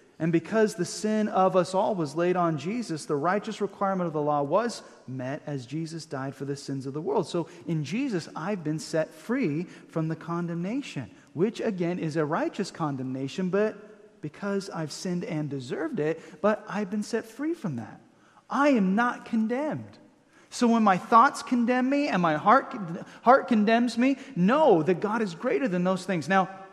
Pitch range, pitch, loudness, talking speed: 160-220 Hz, 185 Hz, -27 LUFS, 185 wpm